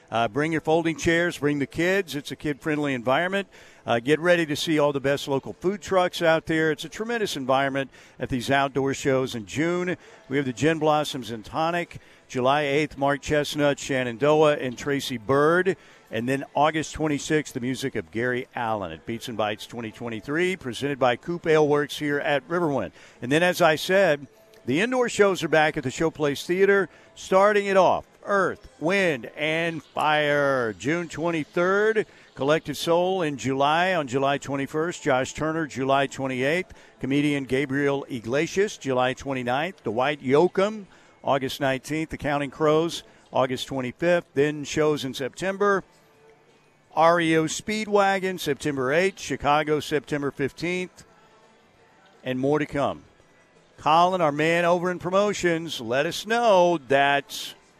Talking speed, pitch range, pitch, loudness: 150 wpm, 135-170 Hz, 150 Hz, -24 LUFS